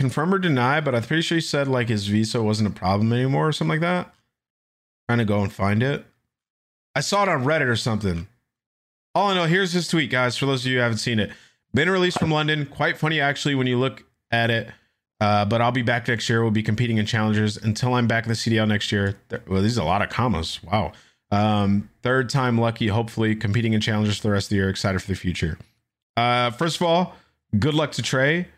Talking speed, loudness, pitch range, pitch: 240 wpm, -22 LUFS, 105-135 Hz, 115 Hz